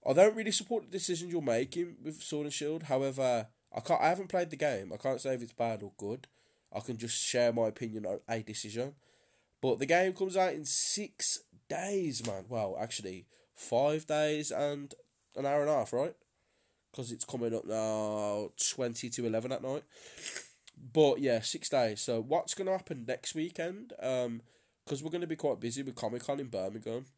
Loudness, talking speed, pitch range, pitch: -33 LUFS, 200 wpm, 115-160 Hz, 130 Hz